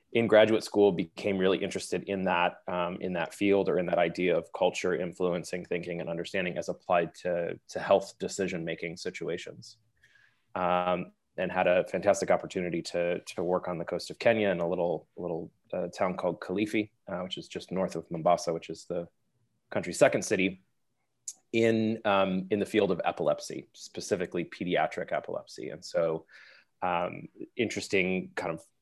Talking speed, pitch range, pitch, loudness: 170 wpm, 90-105 Hz, 95 Hz, -30 LUFS